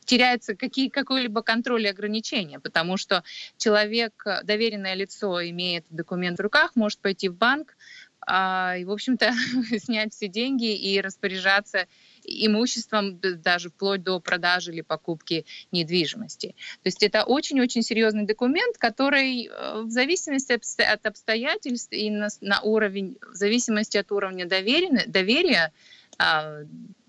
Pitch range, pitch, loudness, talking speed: 190-235 Hz, 215 Hz, -24 LUFS, 125 wpm